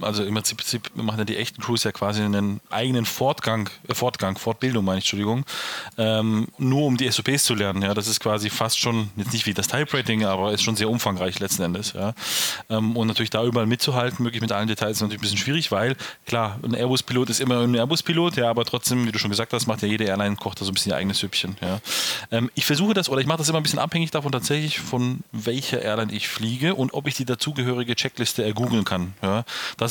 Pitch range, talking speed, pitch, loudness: 105-125 Hz, 240 wpm, 115 Hz, -23 LUFS